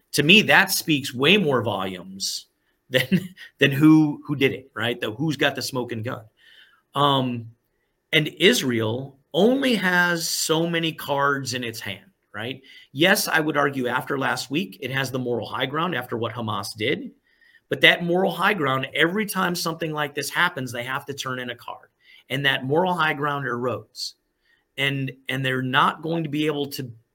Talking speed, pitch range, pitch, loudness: 180 wpm, 125-165 Hz, 140 Hz, -22 LUFS